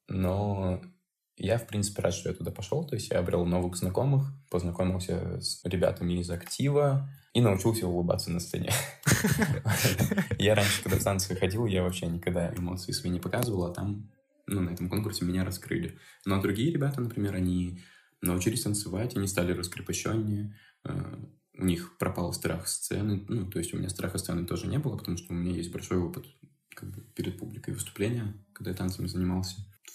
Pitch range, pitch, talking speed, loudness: 90-115 Hz, 95 Hz, 170 wpm, -30 LUFS